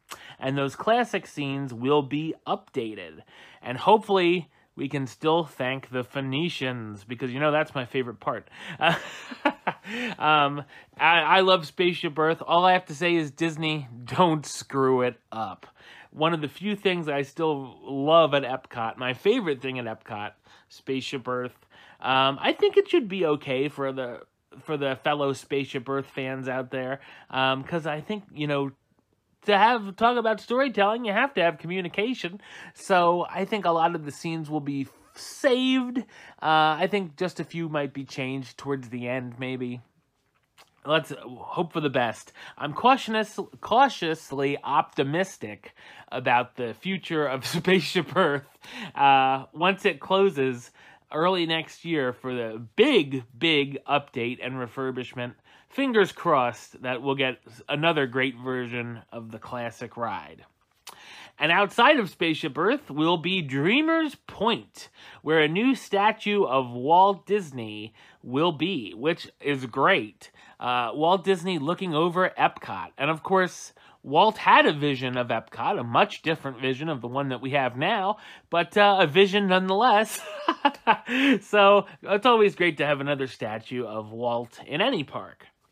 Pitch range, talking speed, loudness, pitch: 130-185 Hz, 155 wpm, -25 LUFS, 150 Hz